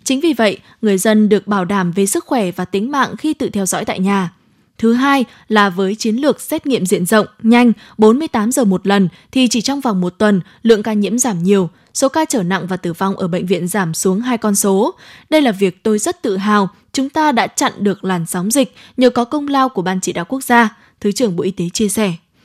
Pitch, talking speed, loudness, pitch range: 215 Hz, 250 wpm, -15 LUFS, 195-250 Hz